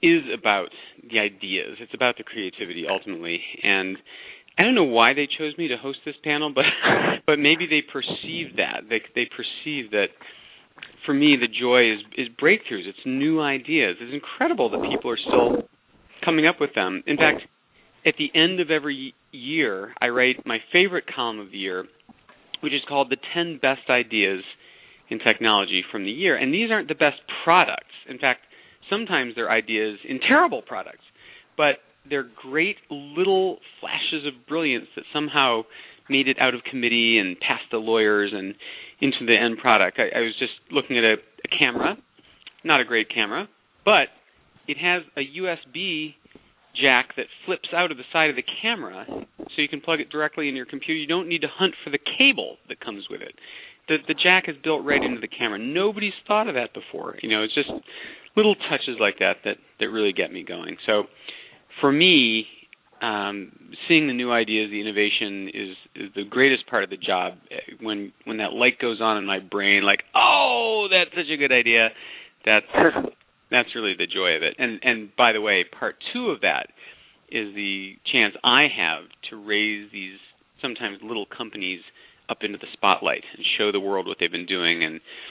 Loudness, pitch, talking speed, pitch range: -22 LUFS, 140 Hz, 190 wpm, 110-165 Hz